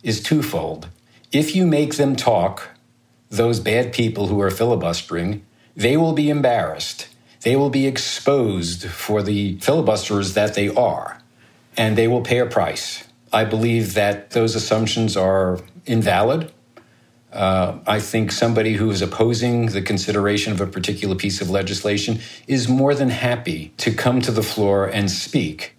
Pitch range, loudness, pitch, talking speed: 100-120 Hz, -20 LUFS, 110 Hz, 155 wpm